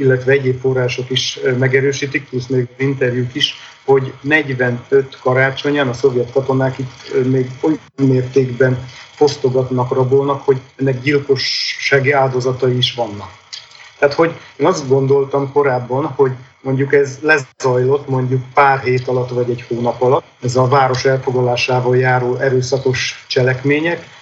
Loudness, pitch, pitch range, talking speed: -15 LUFS, 130 Hz, 125-140 Hz, 130 wpm